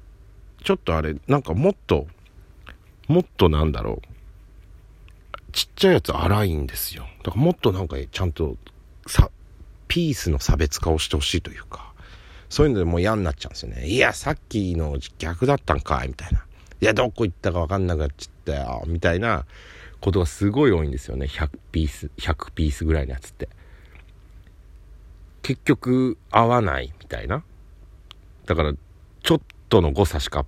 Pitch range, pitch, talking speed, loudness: 80-100 Hz, 90 Hz, 345 characters per minute, -23 LUFS